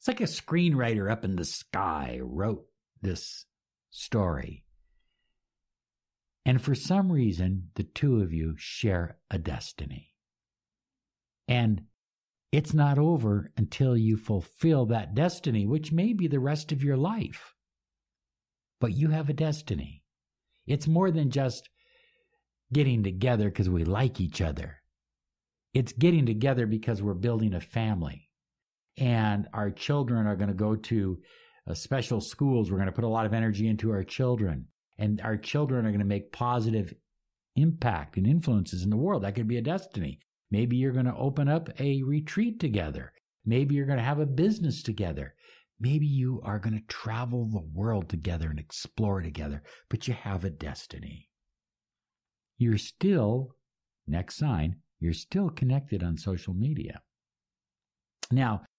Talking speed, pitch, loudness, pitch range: 150 wpm, 115 Hz, -29 LUFS, 100-140 Hz